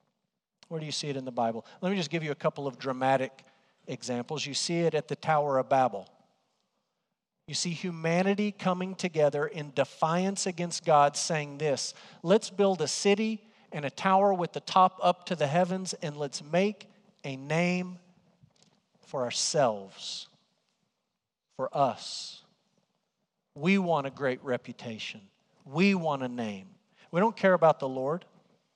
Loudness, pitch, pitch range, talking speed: -29 LUFS, 170 Hz, 145-195 Hz, 155 wpm